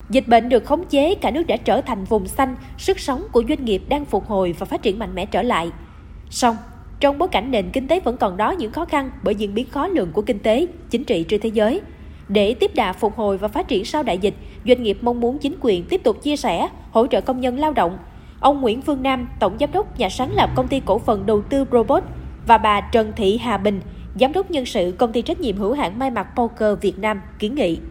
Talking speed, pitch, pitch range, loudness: 260 wpm, 240 Hz, 210-280 Hz, -20 LUFS